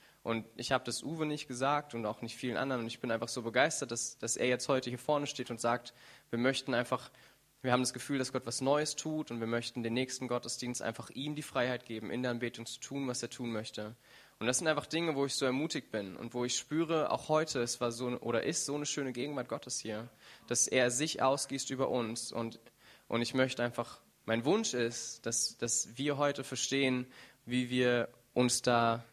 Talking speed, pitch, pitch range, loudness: 225 wpm, 125 Hz, 115-135 Hz, -34 LUFS